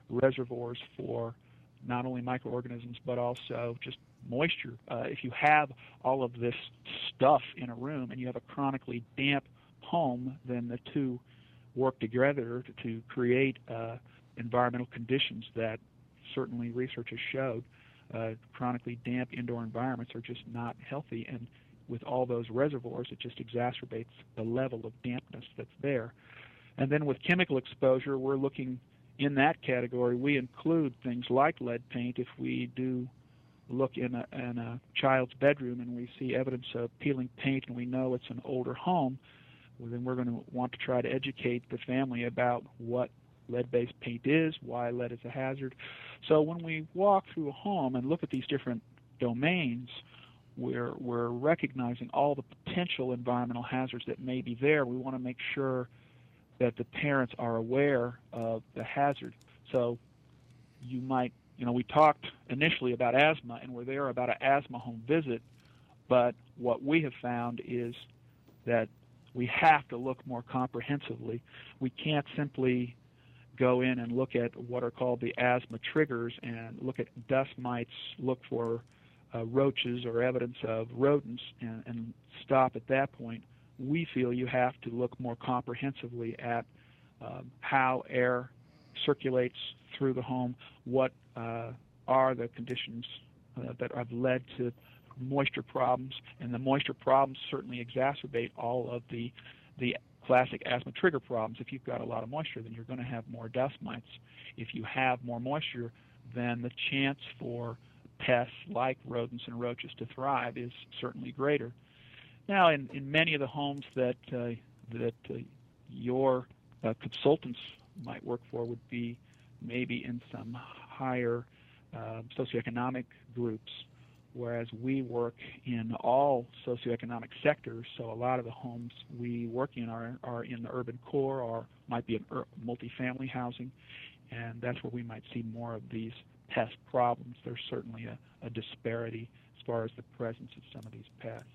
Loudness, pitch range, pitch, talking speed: -33 LUFS, 120-130 Hz, 125 Hz, 165 wpm